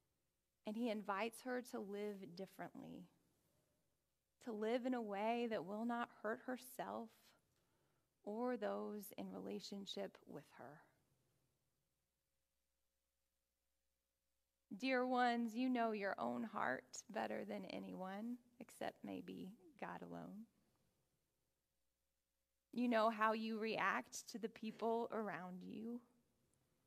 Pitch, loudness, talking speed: 205 Hz, -45 LUFS, 105 wpm